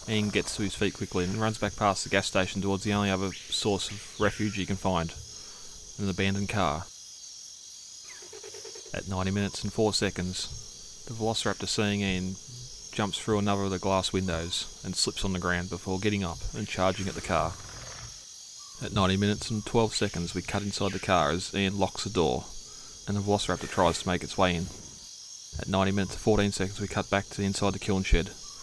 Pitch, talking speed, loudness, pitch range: 100 Hz, 200 wpm, -29 LUFS, 95-105 Hz